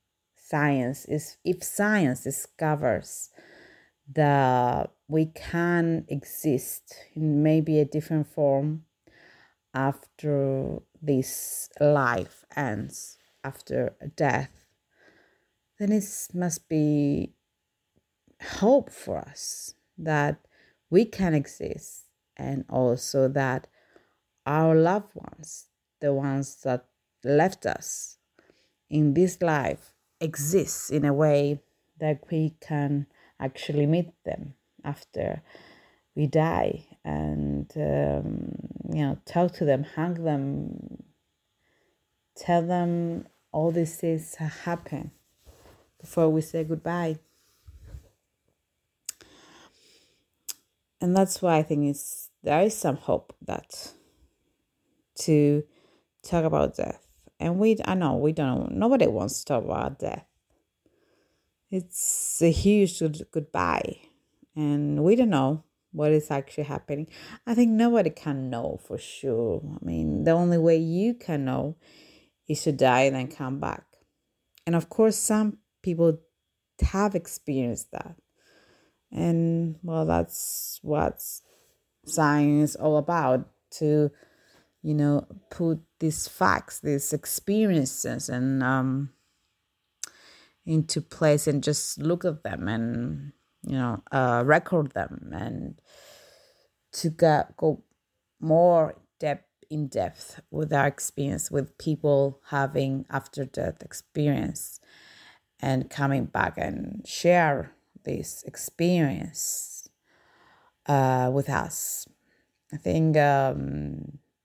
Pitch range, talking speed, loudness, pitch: 135-165 Hz, 110 wpm, -26 LUFS, 150 Hz